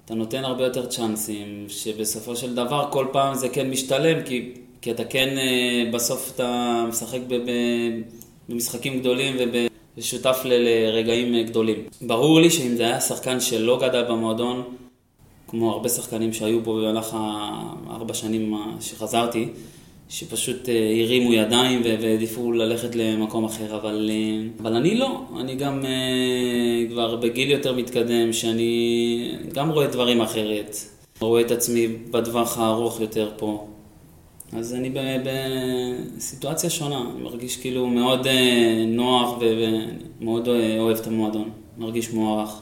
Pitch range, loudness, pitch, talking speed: 115-125 Hz, -23 LUFS, 120 Hz, 125 wpm